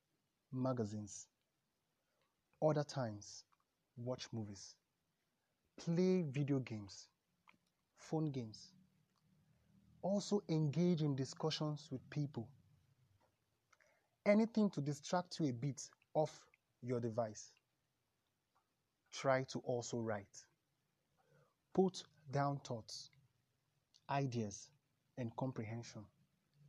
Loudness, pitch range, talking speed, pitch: -41 LUFS, 120-155 Hz, 80 wpm, 140 Hz